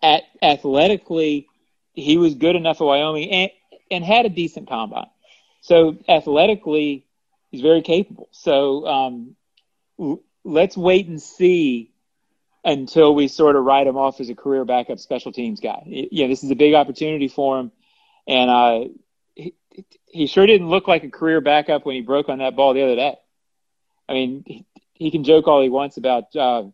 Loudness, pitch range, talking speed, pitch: -18 LUFS, 135-180 Hz, 175 wpm, 150 Hz